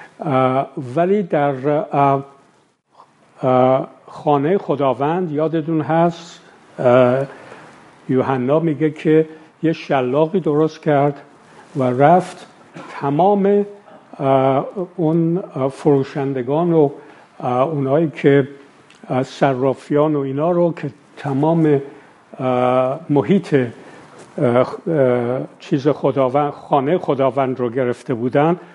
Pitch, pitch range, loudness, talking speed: 145 Hz, 135-160 Hz, -18 LUFS, 80 wpm